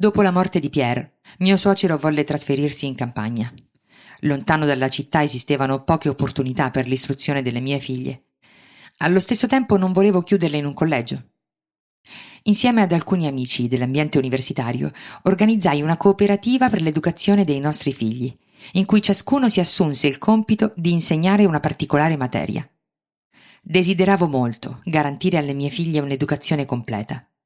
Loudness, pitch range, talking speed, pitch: -19 LUFS, 140-190 Hz, 140 wpm, 155 Hz